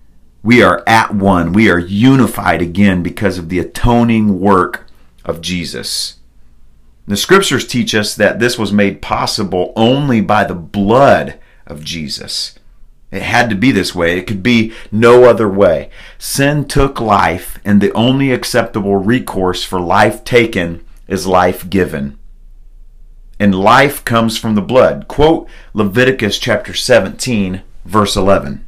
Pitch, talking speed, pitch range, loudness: 100 Hz, 140 wpm, 90-115 Hz, -12 LUFS